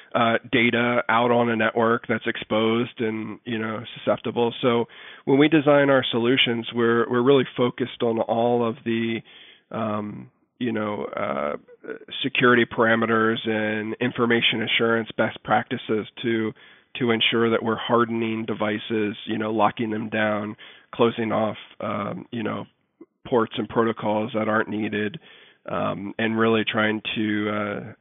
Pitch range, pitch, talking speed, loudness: 110-120 Hz, 115 Hz, 140 wpm, -23 LUFS